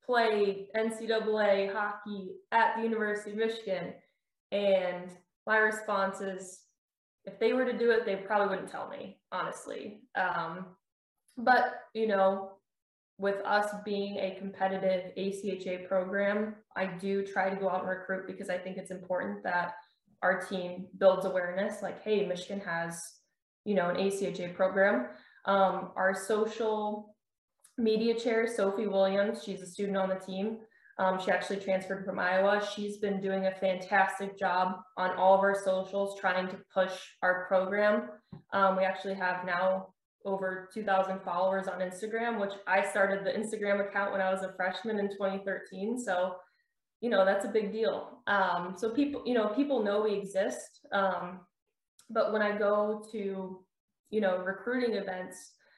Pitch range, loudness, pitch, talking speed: 190-210 Hz, -31 LUFS, 195 Hz, 155 wpm